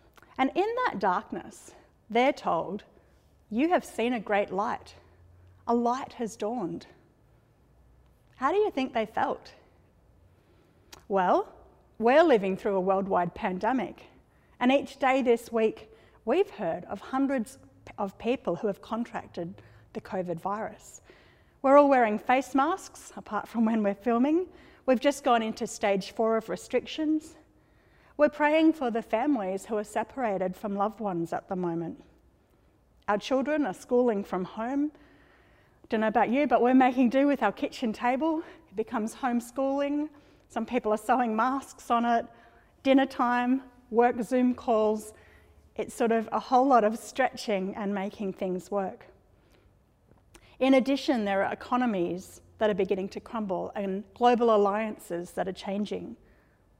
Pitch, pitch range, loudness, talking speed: 235 Hz, 205-265 Hz, -28 LUFS, 145 wpm